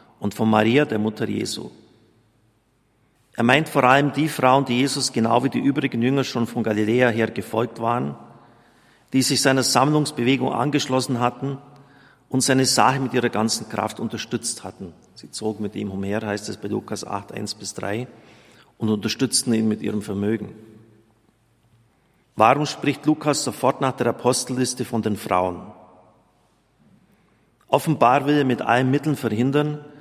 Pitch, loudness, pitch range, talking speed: 120 Hz, -21 LUFS, 110-130 Hz, 150 wpm